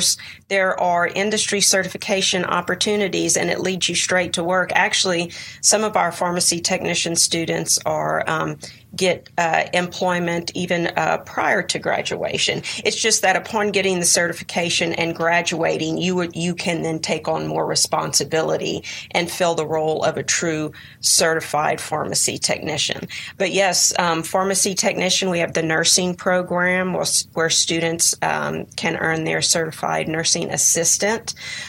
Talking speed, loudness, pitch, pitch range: 145 wpm, -19 LUFS, 175 Hz, 165-185 Hz